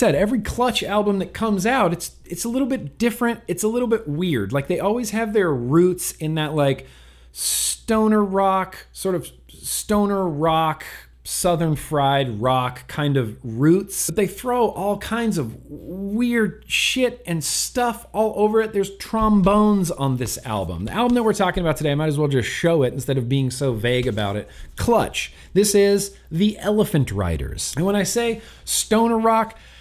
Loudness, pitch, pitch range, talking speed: -21 LUFS, 180 Hz, 140-215 Hz, 180 wpm